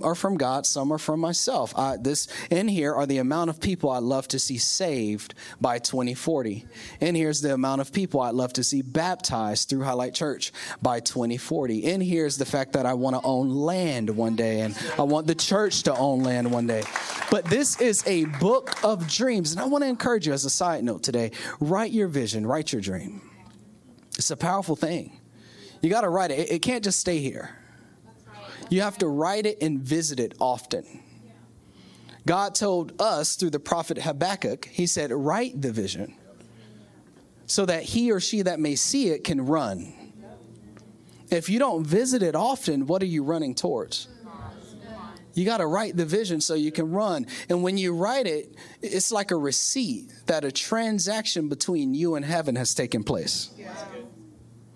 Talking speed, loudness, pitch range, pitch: 190 wpm, -25 LUFS, 130-185 Hz, 155 Hz